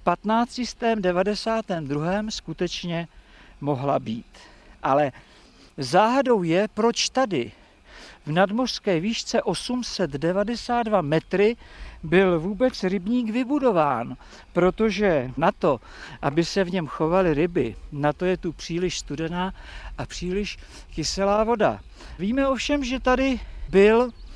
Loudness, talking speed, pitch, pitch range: -24 LUFS, 105 wpm, 200 Hz, 175-230 Hz